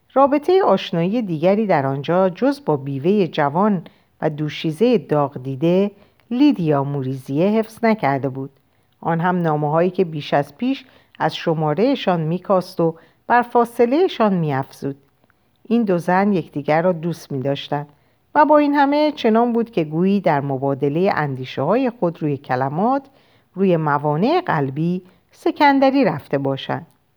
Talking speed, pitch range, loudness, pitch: 135 wpm, 145-225 Hz, -19 LUFS, 175 Hz